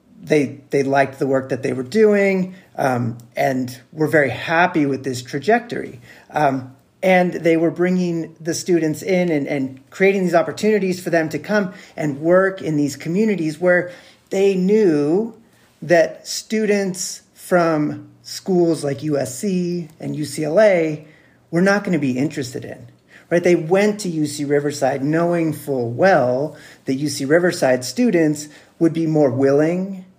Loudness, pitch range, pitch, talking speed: -19 LUFS, 140-180 Hz, 160 Hz, 145 wpm